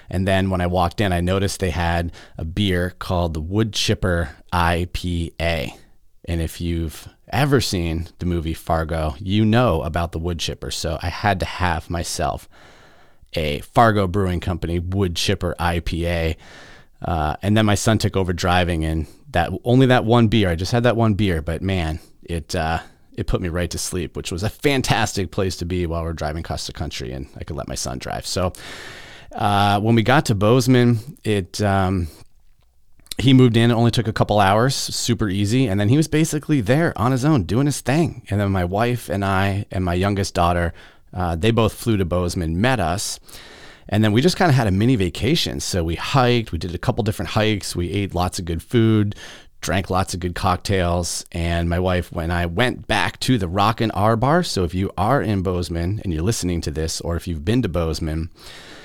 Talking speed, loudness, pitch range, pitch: 205 wpm, -20 LUFS, 85-110 Hz, 95 Hz